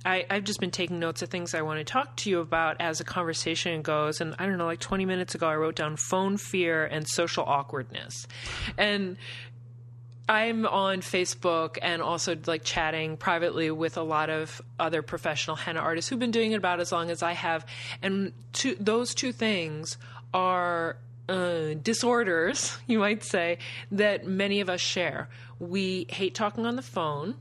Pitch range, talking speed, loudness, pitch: 155-190 Hz, 180 wpm, -28 LUFS, 170 Hz